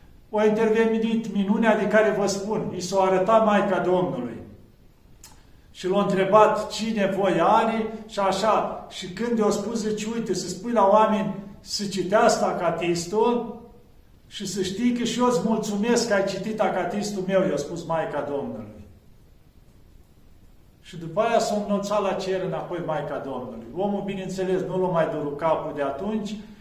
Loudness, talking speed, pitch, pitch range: -24 LUFS, 155 wpm, 200 Hz, 180-215 Hz